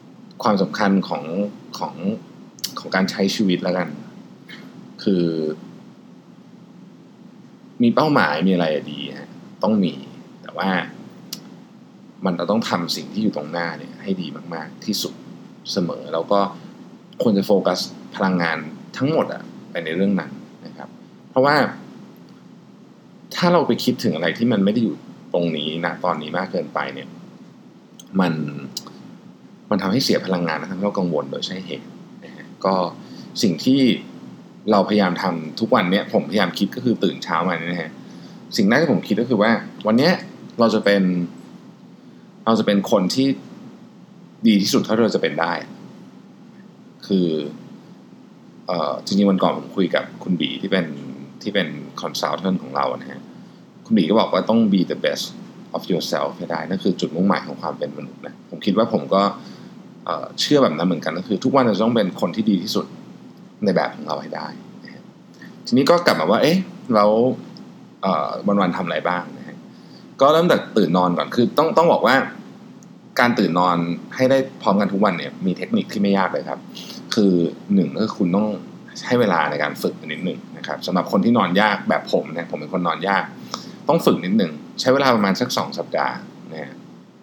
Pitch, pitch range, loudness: 95 Hz, 85-105 Hz, -20 LUFS